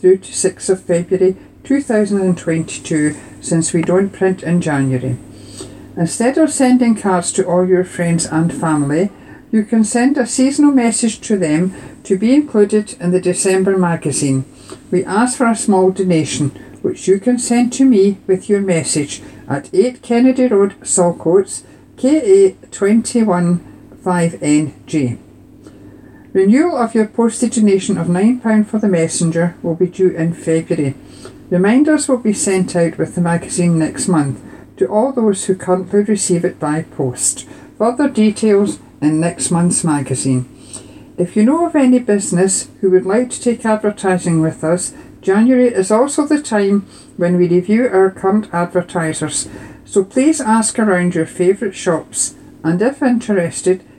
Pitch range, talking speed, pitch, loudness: 170-225 Hz, 150 wpm, 190 Hz, -15 LUFS